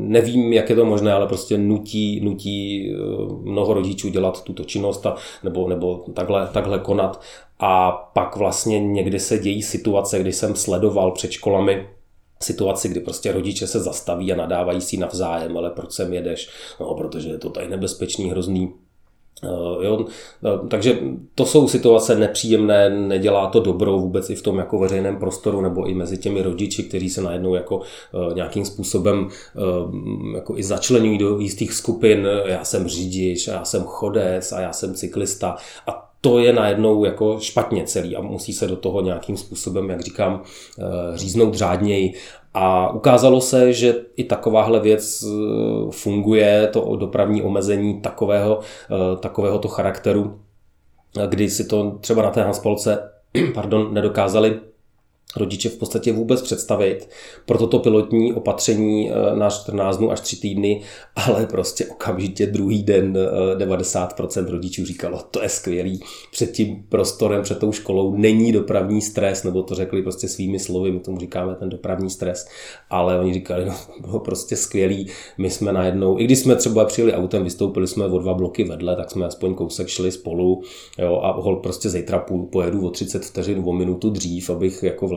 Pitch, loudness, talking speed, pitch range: 100 Hz, -20 LUFS, 160 wpm, 95-105 Hz